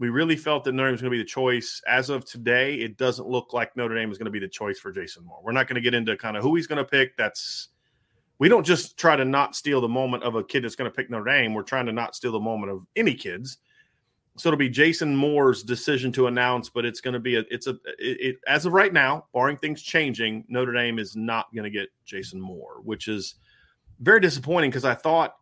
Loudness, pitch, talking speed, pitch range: -24 LUFS, 125 Hz, 265 wpm, 115-135 Hz